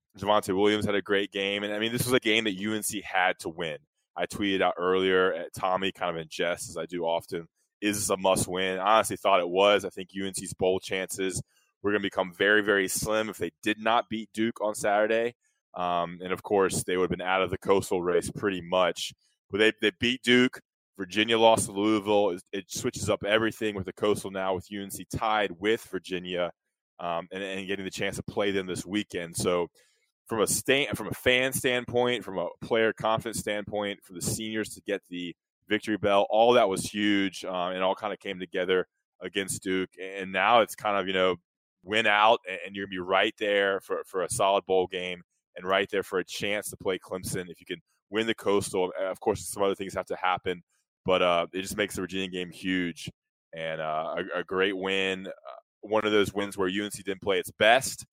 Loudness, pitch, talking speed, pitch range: -27 LUFS, 100 Hz, 220 wpm, 95-105 Hz